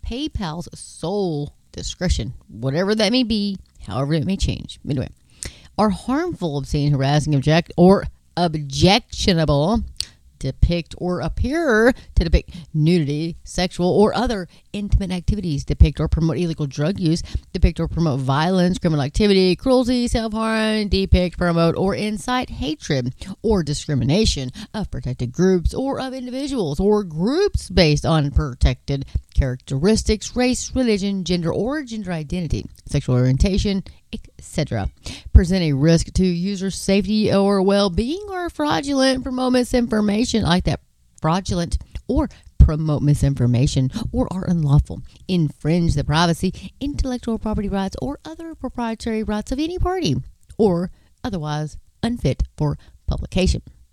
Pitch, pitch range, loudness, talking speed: 180 Hz, 150-220 Hz, -20 LUFS, 125 wpm